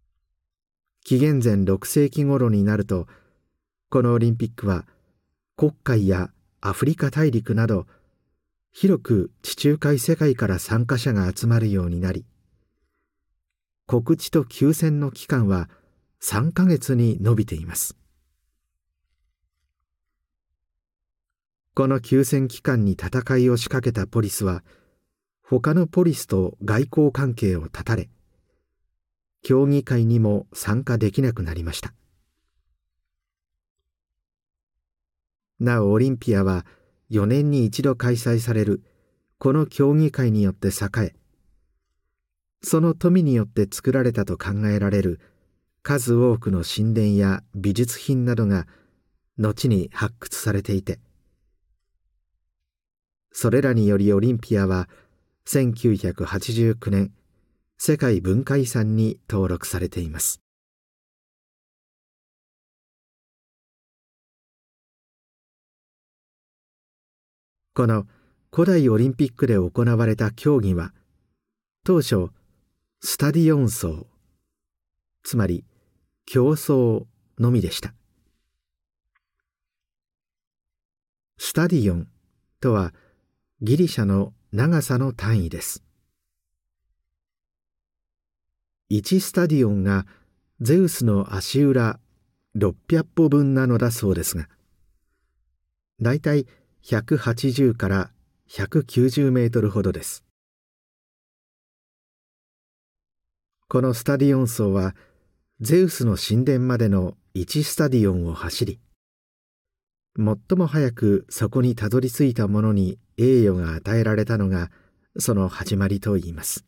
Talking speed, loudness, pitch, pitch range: 190 characters per minute, -22 LUFS, 100 Hz, 85-125 Hz